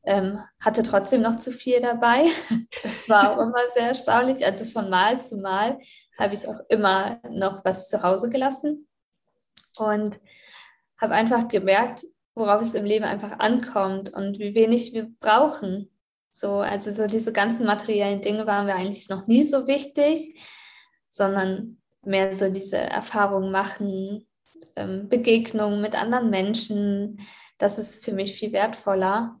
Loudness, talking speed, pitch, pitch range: -23 LUFS, 145 wpm, 215 Hz, 200-235 Hz